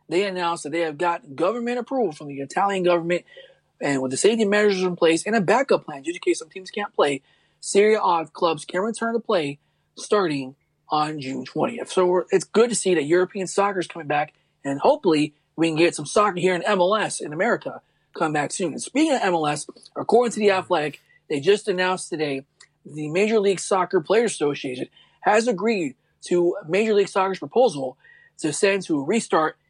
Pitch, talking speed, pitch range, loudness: 185 Hz, 200 wpm, 155-210 Hz, -22 LUFS